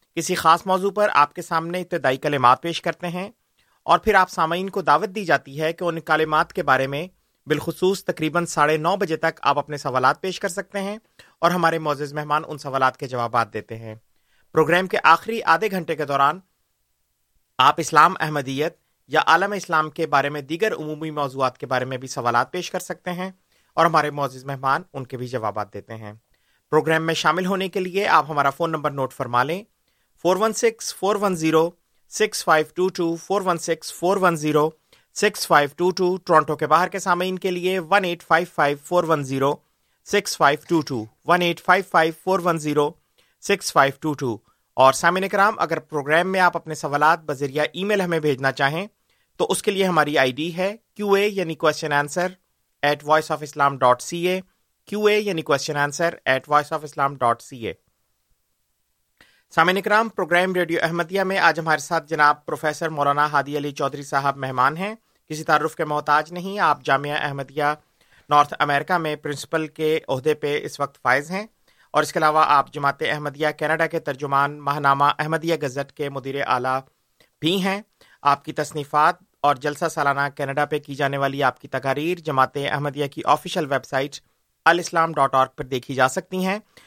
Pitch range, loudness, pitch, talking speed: 140-180 Hz, -21 LUFS, 155 Hz, 195 wpm